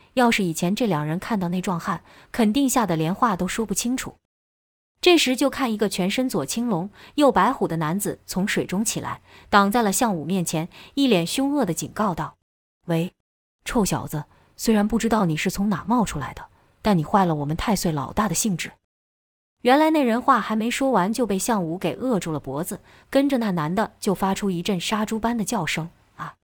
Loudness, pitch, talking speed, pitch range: -23 LUFS, 200 Hz, 280 characters per minute, 170-235 Hz